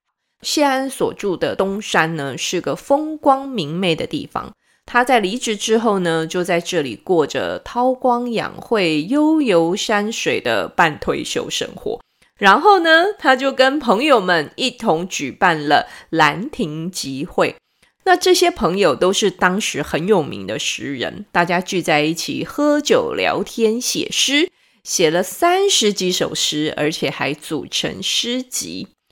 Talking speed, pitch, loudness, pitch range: 210 characters per minute, 220 Hz, -17 LUFS, 175-275 Hz